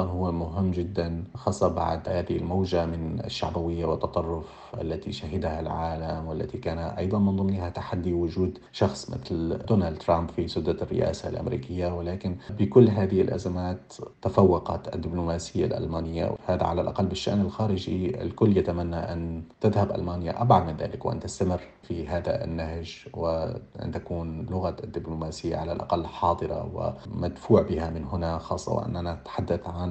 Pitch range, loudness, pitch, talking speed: 85-95 Hz, -28 LUFS, 85 Hz, 135 wpm